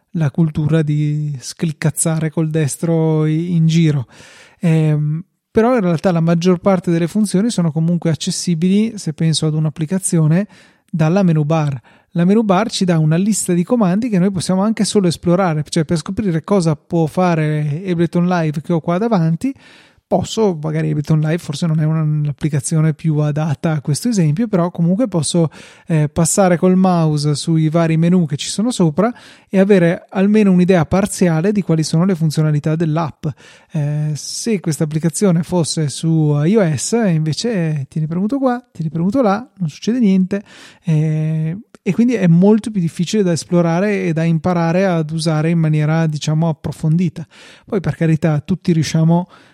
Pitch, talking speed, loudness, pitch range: 170 Hz, 160 wpm, -16 LUFS, 155-190 Hz